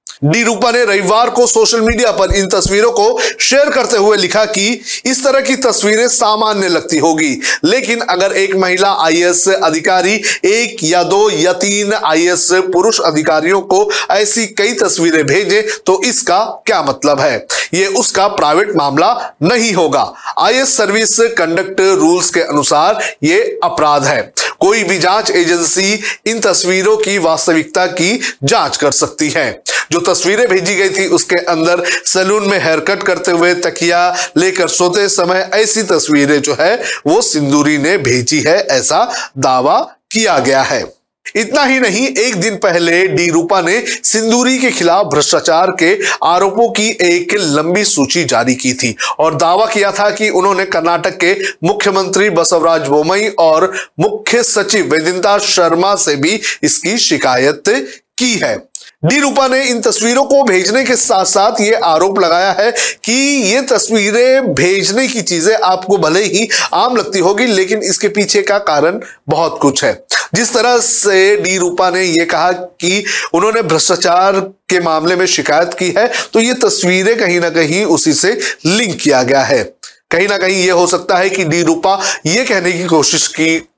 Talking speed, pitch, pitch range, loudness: 165 wpm, 195 Hz, 175-225 Hz, -11 LUFS